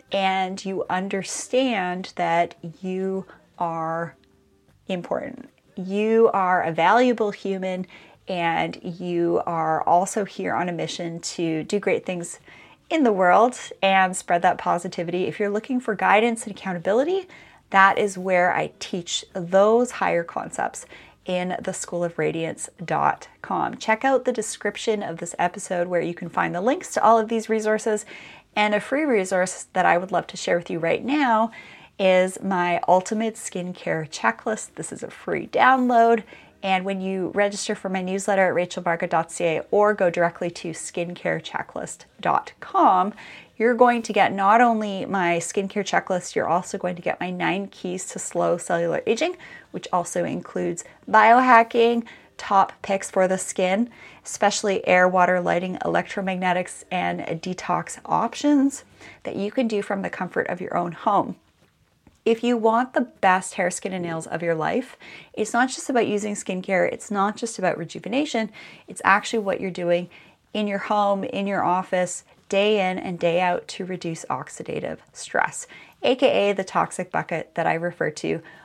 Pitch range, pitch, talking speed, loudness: 175-215 Hz, 190 Hz, 155 wpm, -23 LUFS